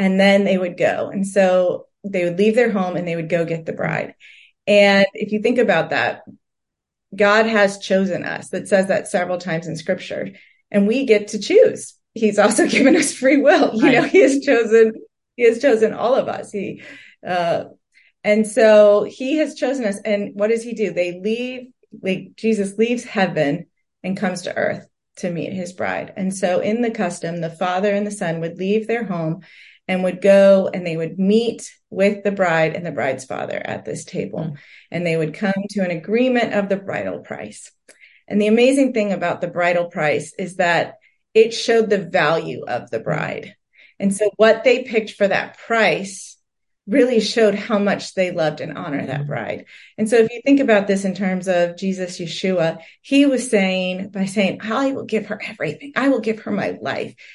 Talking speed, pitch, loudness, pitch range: 200 wpm, 200 Hz, -18 LUFS, 180-225 Hz